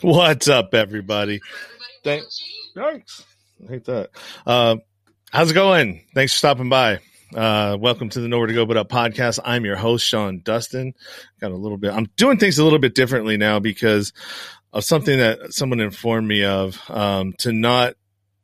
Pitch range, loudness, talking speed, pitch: 105-135 Hz, -19 LUFS, 175 wpm, 115 Hz